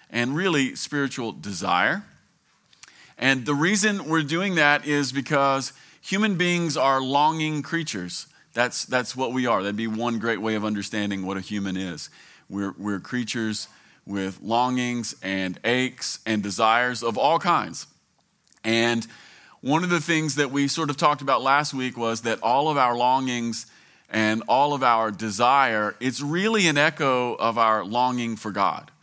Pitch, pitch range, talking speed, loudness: 125 Hz, 110-145 Hz, 160 wpm, -23 LUFS